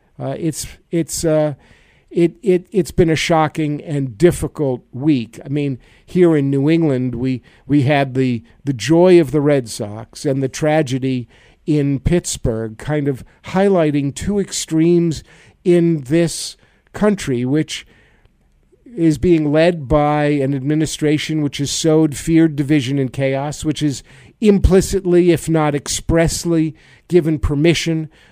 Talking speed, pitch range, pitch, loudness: 135 wpm, 135-165 Hz, 150 Hz, -17 LUFS